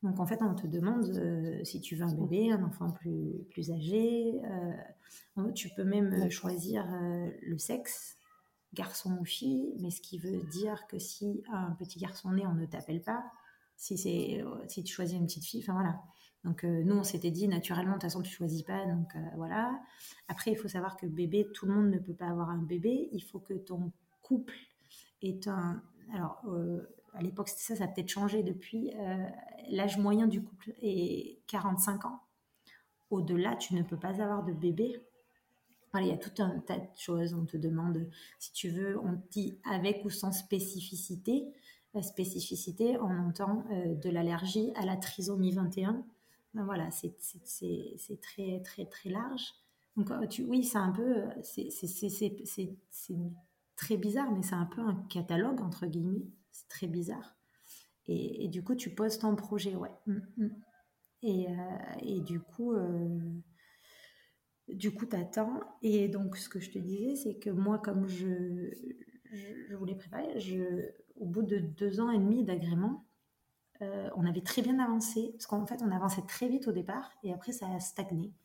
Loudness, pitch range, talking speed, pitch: -35 LUFS, 180-215 Hz, 190 wpm, 195 Hz